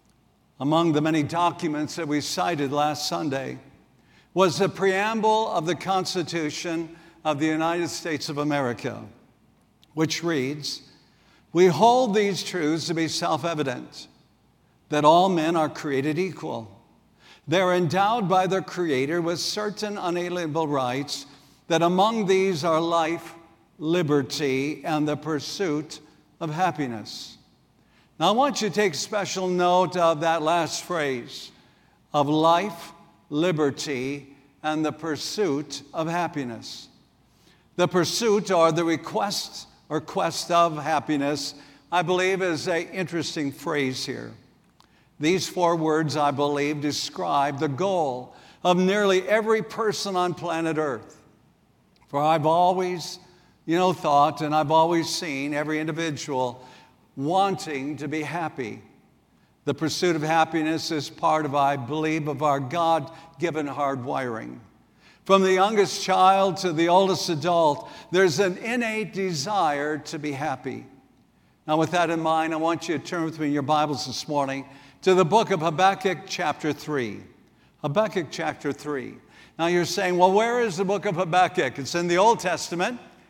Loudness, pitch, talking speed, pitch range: -24 LUFS, 165 Hz, 140 wpm, 150-180 Hz